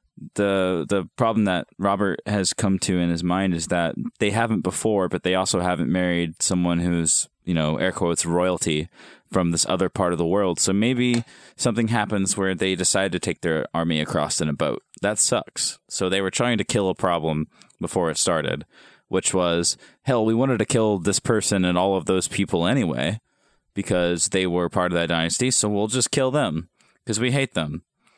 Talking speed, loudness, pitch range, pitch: 200 wpm, -22 LUFS, 85-105 Hz, 95 Hz